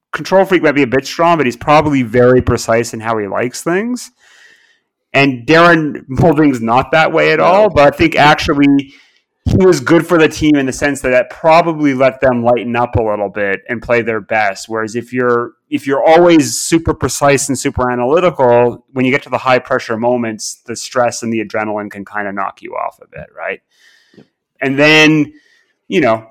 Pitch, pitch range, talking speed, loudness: 135 Hz, 120-155 Hz, 205 wpm, -12 LUFS